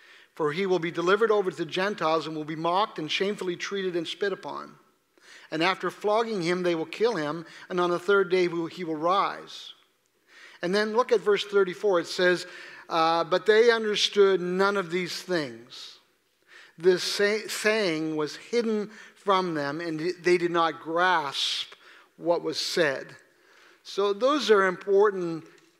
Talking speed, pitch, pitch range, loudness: 165 wpm, 185 Hz, 170-205 Hz, -26 LUFS